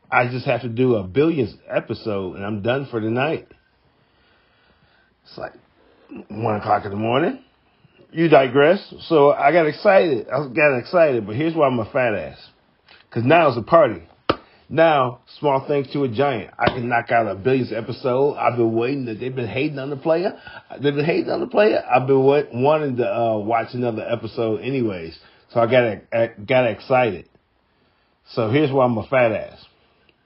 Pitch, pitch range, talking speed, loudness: 125 Hz, 115-145 Hz, 180 wpm, -20 LUFS